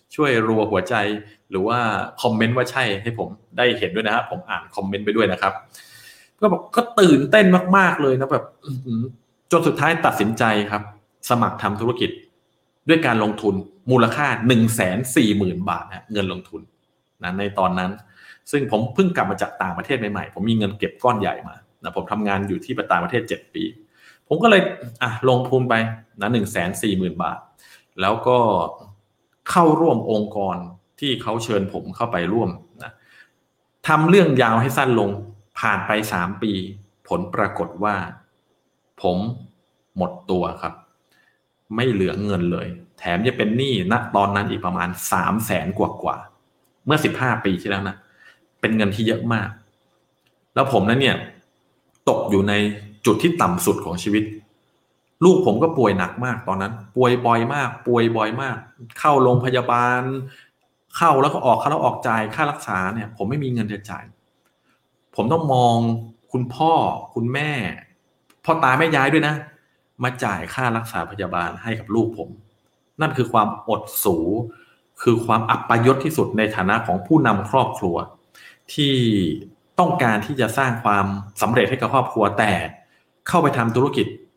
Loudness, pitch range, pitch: -20 LUFS, 105-130 Hz, 115 Hz